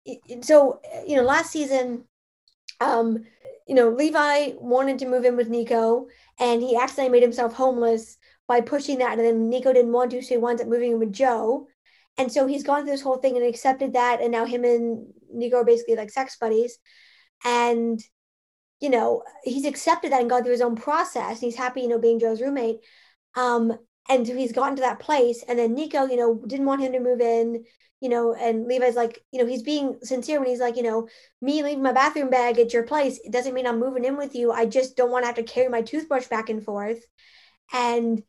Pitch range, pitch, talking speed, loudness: 235-265 Hz, 245 Hz, 225 wpm, -23 LUFS